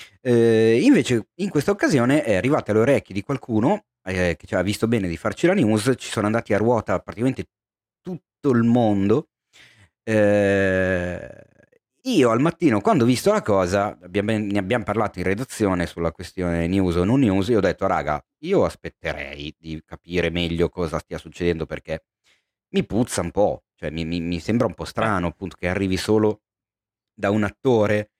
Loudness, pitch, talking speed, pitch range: -21 LUFS, 100 Hz, 175 wpm, 90-115 Hz